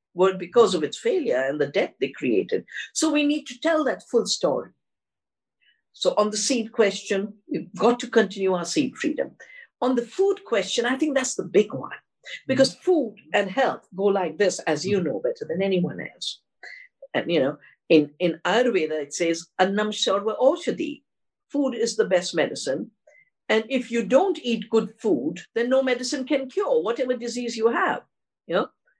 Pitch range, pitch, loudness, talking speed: 200-280 Hz, 235 Hz, -24 LUFS, 180 wpm